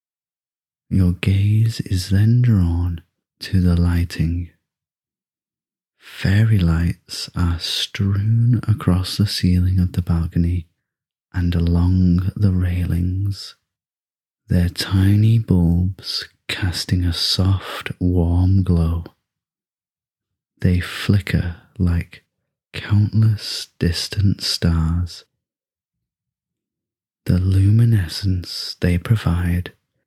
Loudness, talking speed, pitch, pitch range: -19 LUFS, 80 wpm, 90 Hz, 85-100 Hz